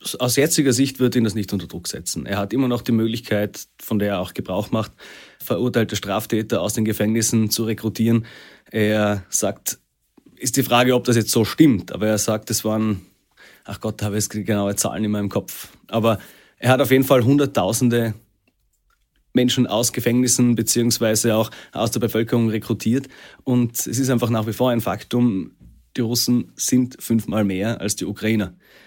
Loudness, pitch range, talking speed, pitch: -20 LUFS, 105-120 Hz, 180 wpm, 115 Hz